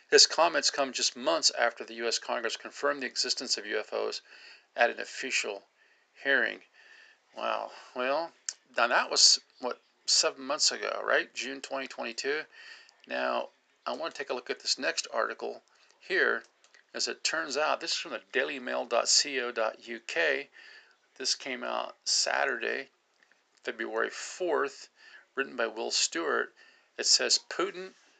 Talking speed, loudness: 135 wpm, -29 LUFS